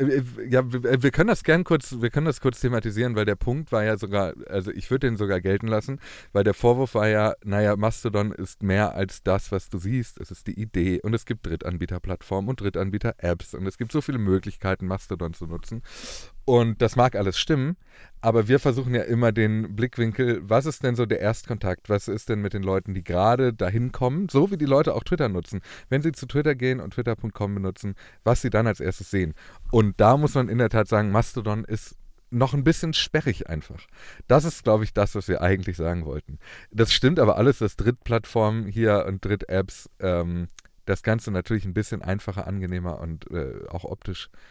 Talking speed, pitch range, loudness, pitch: 205 wpm, 95-125 Hz, -24 LUFS, 110 Hz